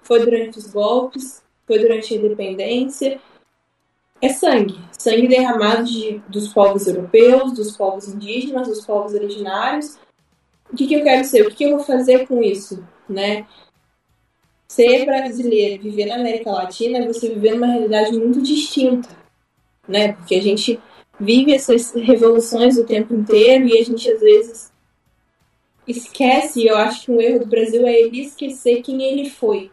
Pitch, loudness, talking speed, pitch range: 235 Hz, -16 LUFS, 160 wpm, 215-260 Hz